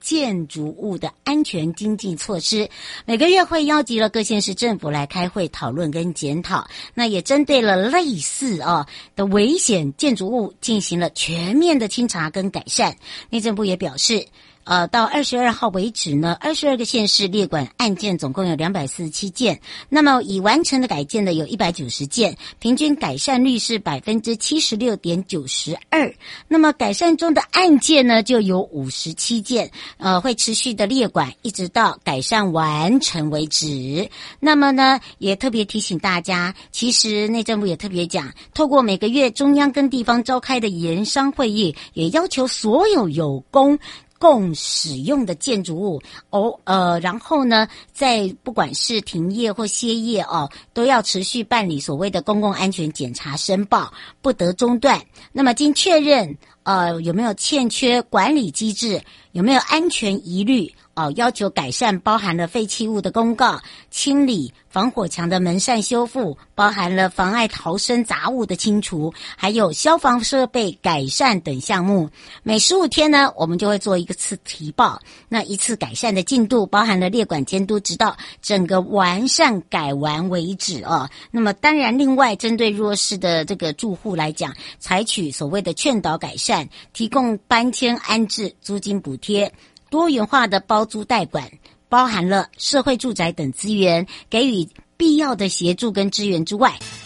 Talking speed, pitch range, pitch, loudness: 255 characters per minute, 175-245 Hz, 210 Hz, -19 LUFS